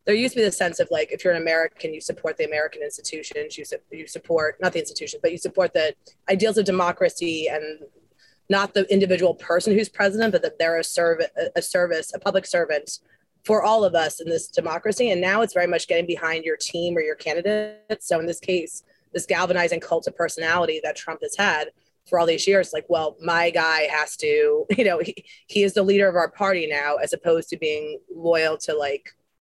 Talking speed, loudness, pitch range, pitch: 220 wpm, -22 LUFS, 165-215 Hz, 180 Hz